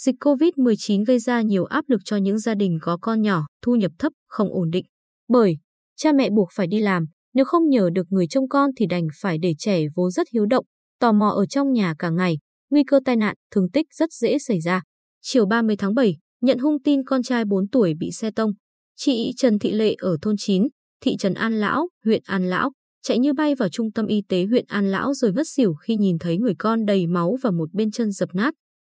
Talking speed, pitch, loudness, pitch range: 240 wpm, 220 Hz, -21 LUFS, 190-255 Hz